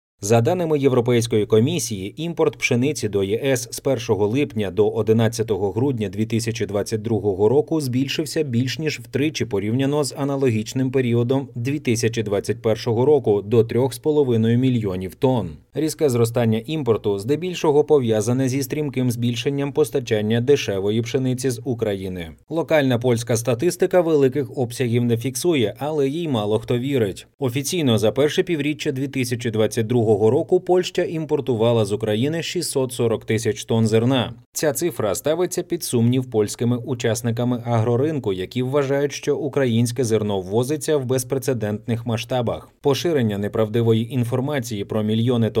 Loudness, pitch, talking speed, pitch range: -21 LUFS, 125 Hz, 120 wpm, 110-140 Hz